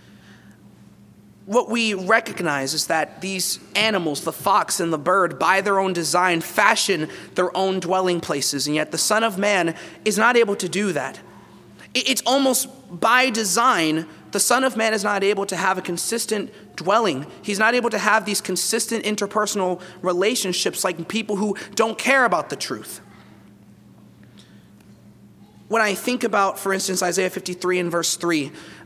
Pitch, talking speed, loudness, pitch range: 190 Hz, 160 wpm, -20 LUFS, 175-220 Hz